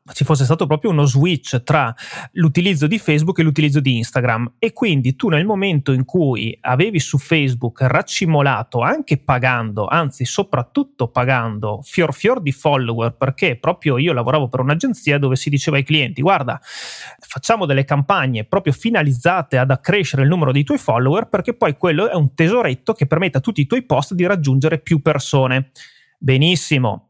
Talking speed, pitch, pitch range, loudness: 170 wpm, 145 Hz, 130-165 Hz, -17 LUFS